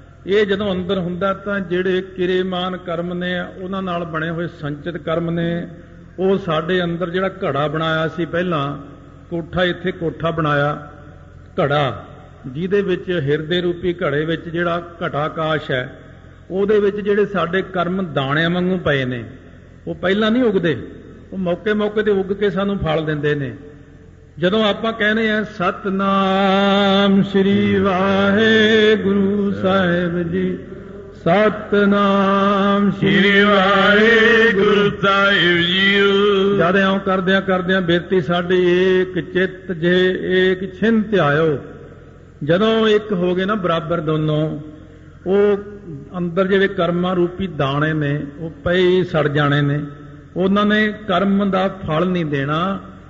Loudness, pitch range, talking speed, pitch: -17 LUFS, 165-195 Hz, 130 wpm, 185 Hz